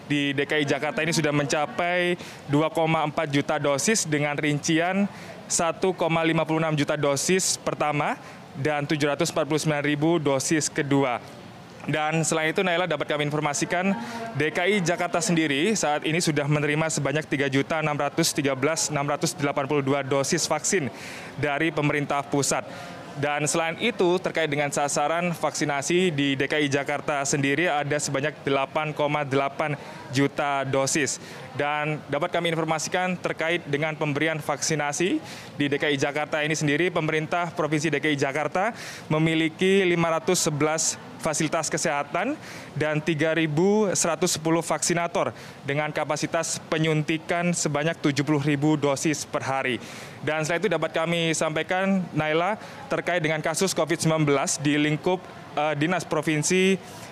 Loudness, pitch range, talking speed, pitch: -24 LUFS, 145-170 Hz, 110 wpm, 155 Hz